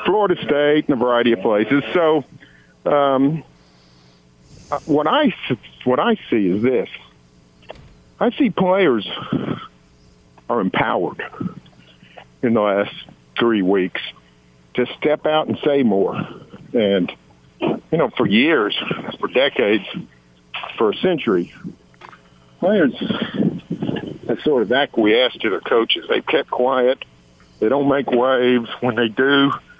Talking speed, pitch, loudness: 120 wpm, 120 Hz, -19 LUFS